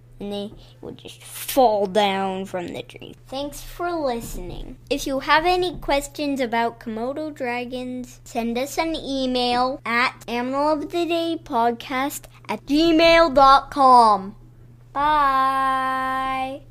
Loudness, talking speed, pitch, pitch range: -21 LUFS, 105 wpm, 260 Hz, 230-290 Hz